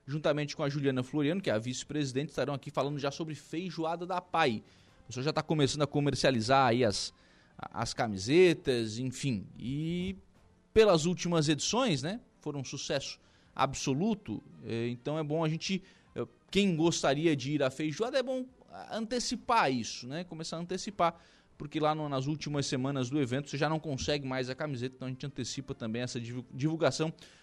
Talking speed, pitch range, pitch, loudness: 170 wpm, 130-165 Hz, 145 Hz, -32 LUFS